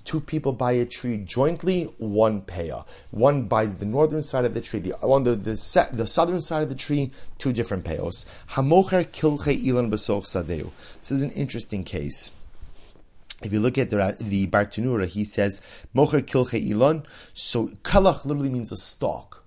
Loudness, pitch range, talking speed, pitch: -24 LUFS, 105-145 Hz, 165 wpm, 120 Hz